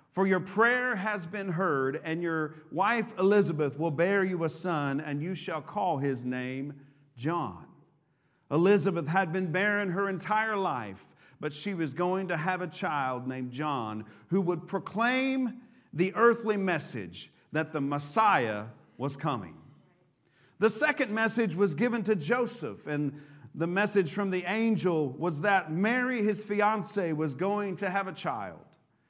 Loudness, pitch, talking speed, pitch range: -29 LUFS, 180 Hz, 155 wpm, 150-205 Hz